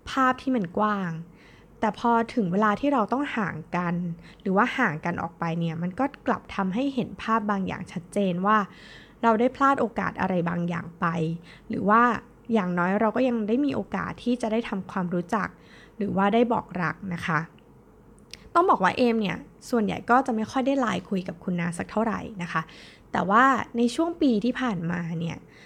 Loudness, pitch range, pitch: -26 LUFS, 175-240 Hz, 210 Hz